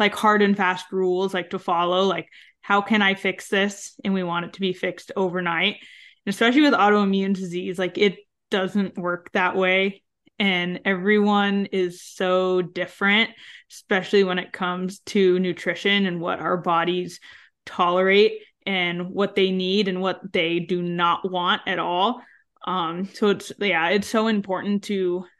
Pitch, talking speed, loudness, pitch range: 190 Hz, 165 wpm, -22 LUFS, 180-200 Hz